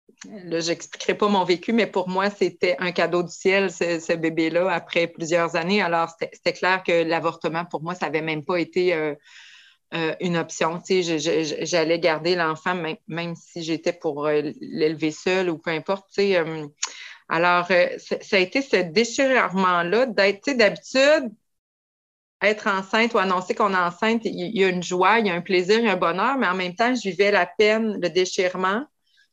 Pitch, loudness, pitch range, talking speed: 180 Hz, -22 LUFS, 170-200 Hz, 190 wpm